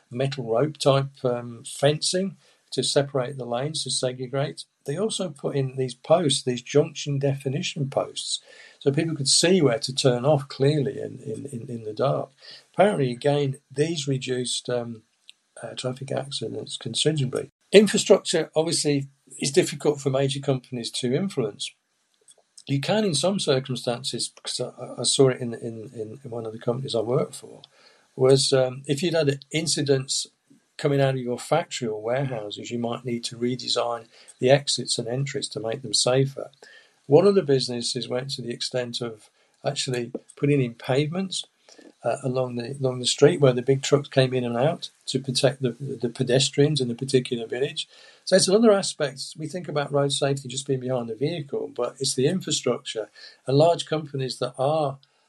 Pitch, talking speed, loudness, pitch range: 135 Hz, 170 wpm, -24 LUFS, 125-145 Hz